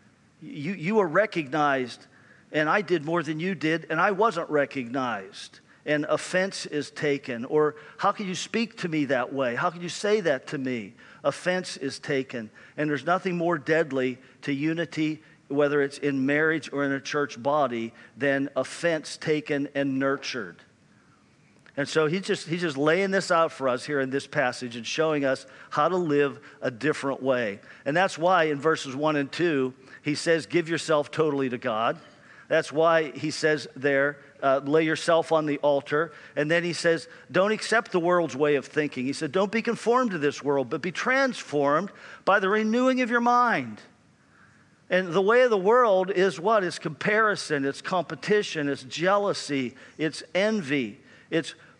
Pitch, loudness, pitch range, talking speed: 155 Hz, -26 LUFS, 140-180 Hz, 180 wpm